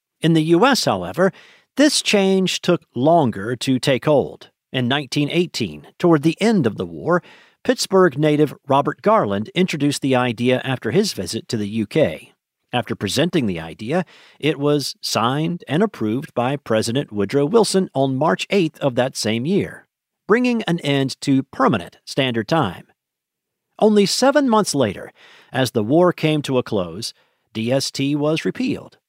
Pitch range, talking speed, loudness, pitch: 125-180 Hz, 150 wpm, -19 LUFS, 145 Hz